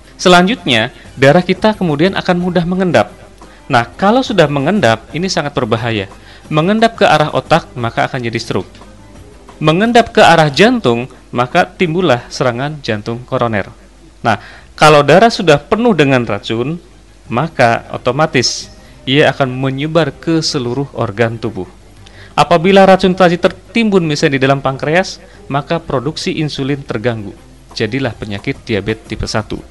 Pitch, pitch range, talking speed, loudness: 140 Hz, 115-175 Hz, 130 wpm, -13 LUFS